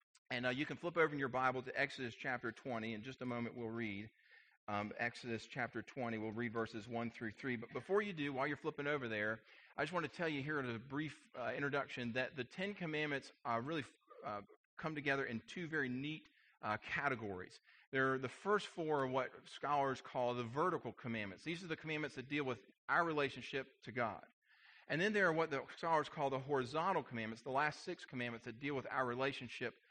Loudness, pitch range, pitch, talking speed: -41 LUFS, 120-150 Hz, 130 Hz, 215 wpm